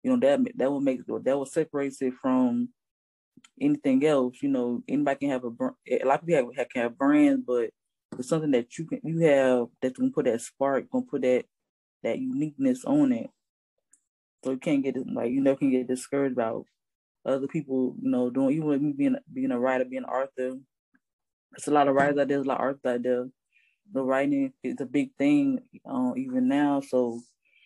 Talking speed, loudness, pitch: 215 wpm, -27 LUFS, 140 Hz